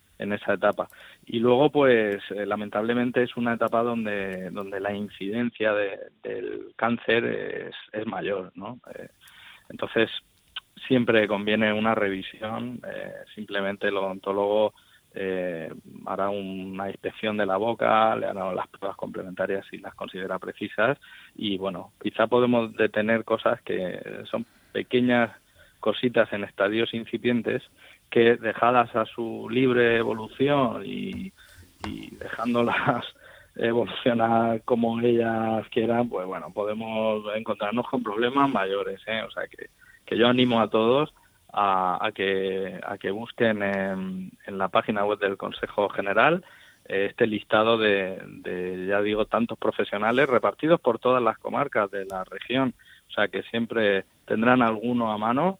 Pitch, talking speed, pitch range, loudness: 110 Hz, 140 wpm, 100-120 Hz, -25 LUFS